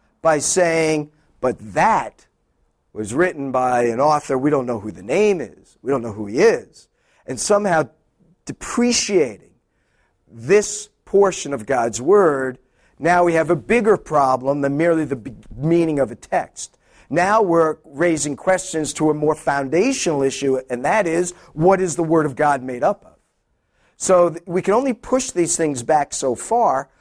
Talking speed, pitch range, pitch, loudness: 170 wpm, 140-180 Hz, 160 Hz, -19 LUFS